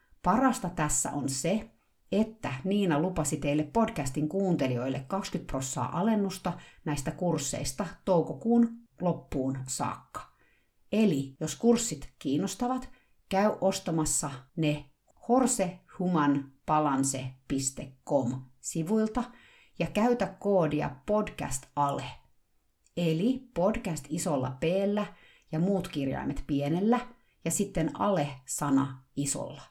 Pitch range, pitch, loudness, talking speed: 145-200 Hz, 165 Hz, -30 LUFS, 90 wpm